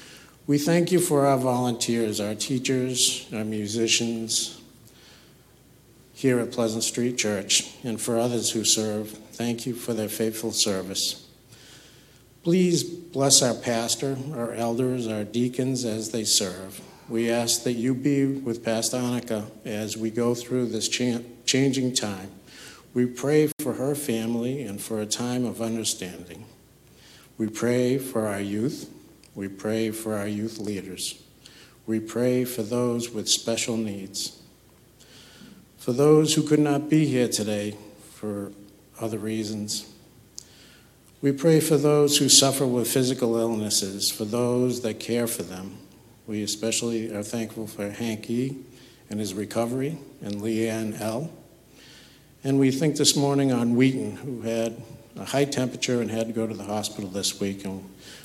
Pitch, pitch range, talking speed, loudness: 115 Hz, 110-130 Hz, 145 wpm, -25 LUFS